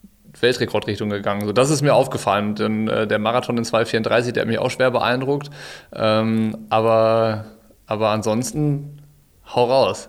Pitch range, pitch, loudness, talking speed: 110-125 Hz, 110 Hz, -20 LUFS, 150 wpm